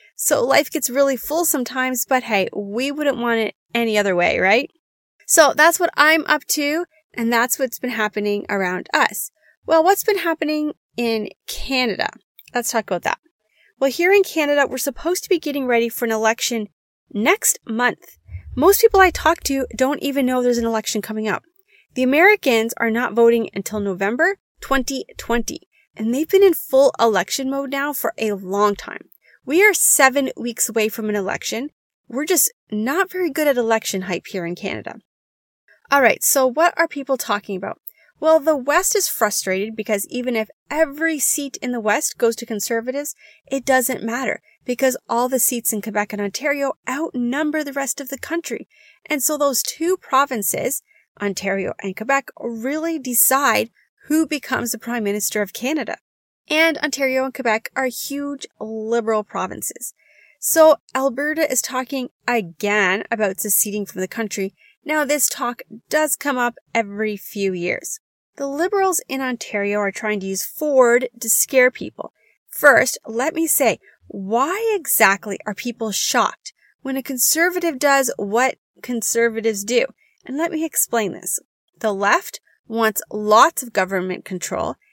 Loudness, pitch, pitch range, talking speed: -19 LUFS, 255 Hz, 220-300 Hz, 165 wpm